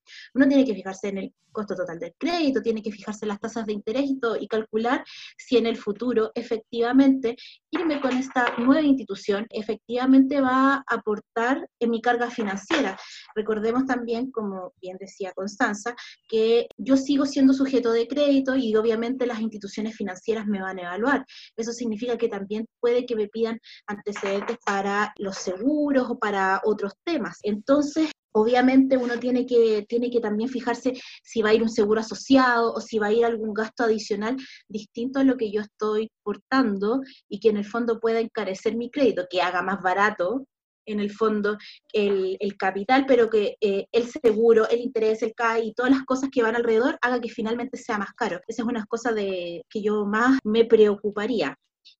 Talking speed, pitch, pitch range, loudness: 185 wpm, 230 Hz, 210-250 Hz, -24 LUFS